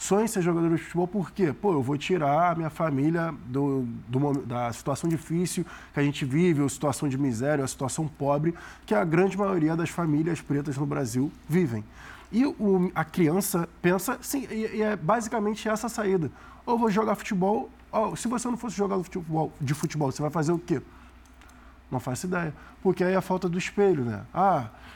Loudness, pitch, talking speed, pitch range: -27 LUFS, 165 Hz, 200 wpm, 140-190 Hz